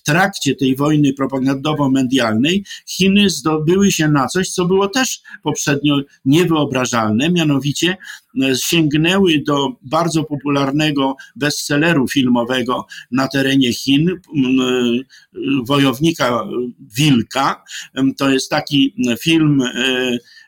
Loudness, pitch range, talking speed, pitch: -16 LUFS, 135-160 Hz, 90 wpm, 145 Hz